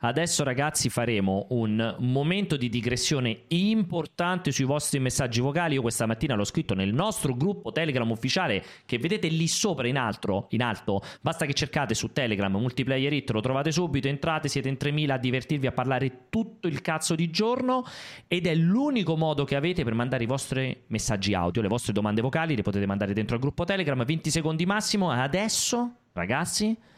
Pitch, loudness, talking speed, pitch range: 140 Hz, -27 LUFS, 180 wpm, 120-170 Hz